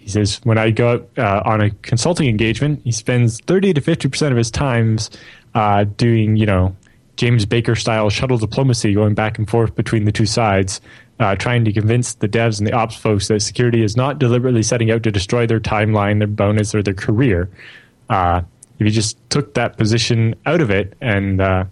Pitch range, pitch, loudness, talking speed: 105-120 Hz, 110 Hz, -17 LUFS, 205 wpm